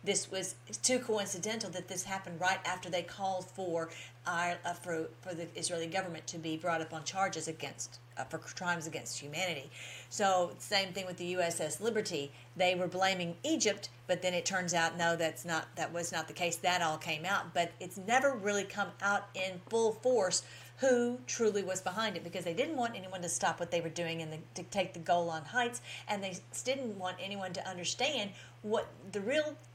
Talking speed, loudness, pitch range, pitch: 200 wpm, -35 LUFS, 165-195 Hz, 180 Hz